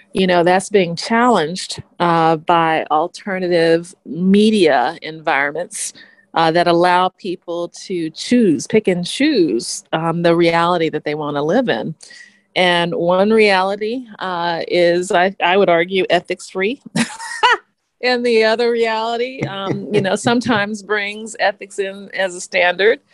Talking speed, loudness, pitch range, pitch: 135 wpm, -16 LUFS, 170-220 Hz, 185 Hz